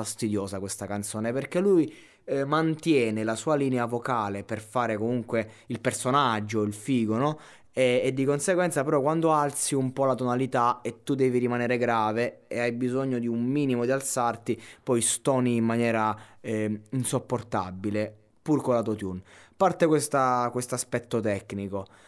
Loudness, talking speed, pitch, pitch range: -27 LUFS, 160 wpm, 120 Hz, 110-135 Hz